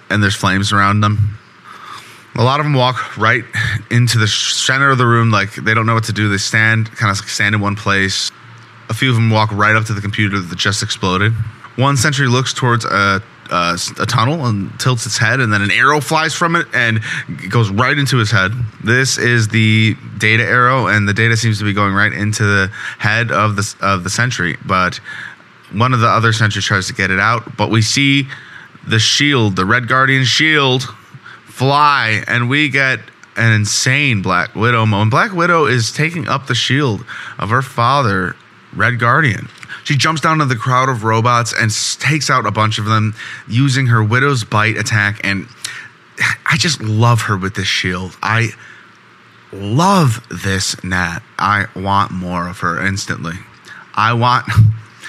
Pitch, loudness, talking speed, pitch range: 110 Hz, -14 LUFS, 190 wpm, 105-125 Hz